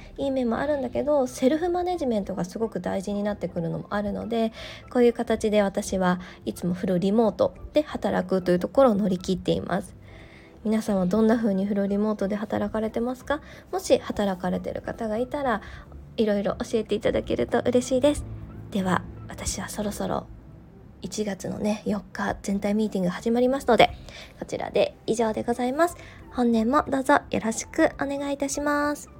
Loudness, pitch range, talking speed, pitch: -25 LUFS, 200-260 Hz, 375 characters per minute, 220 Hz